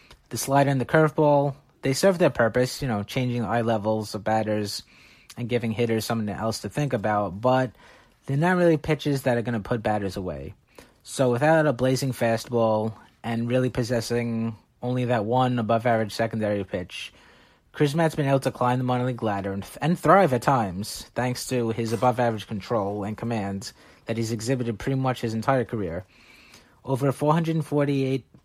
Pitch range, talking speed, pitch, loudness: 110-135 Hz, 175 wpm, 120 Hz, -25 LUFS